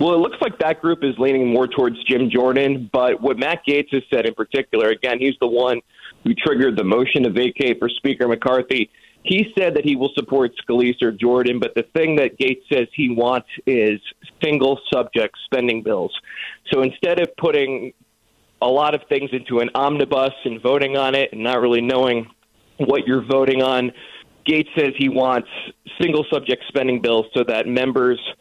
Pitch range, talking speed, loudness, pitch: 125-140 Hz, 190 wpm, -19 LUFS, 130 Hz